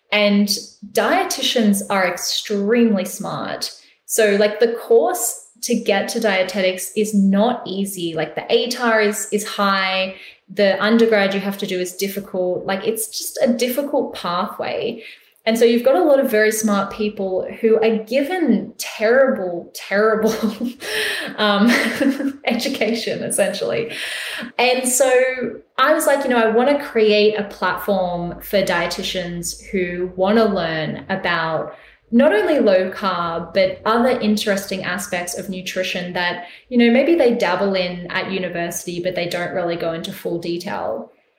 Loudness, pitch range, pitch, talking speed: -19 LUFS, 185-235 Hz, 205 Hz, 145 wpm